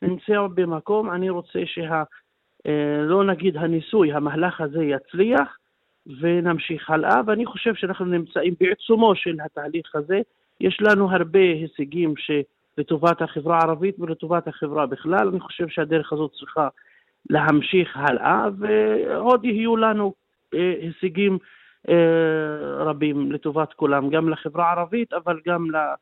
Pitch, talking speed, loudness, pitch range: 170 Hz, 115 wpm, -22 LUFS, 155-190 Hz